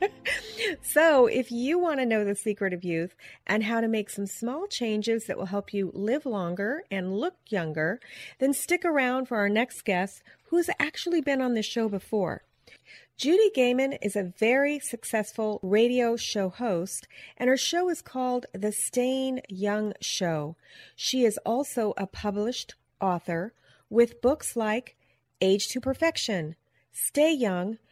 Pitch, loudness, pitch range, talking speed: 230 Hz, -27 LUFS, 200-260 Hz, 155 wpm